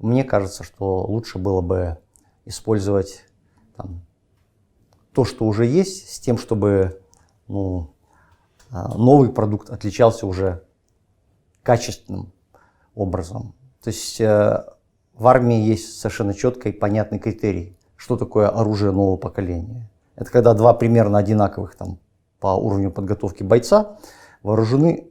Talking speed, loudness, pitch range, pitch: 115 wpm, -19 LUFS, 95-115 Hz, 105 Hz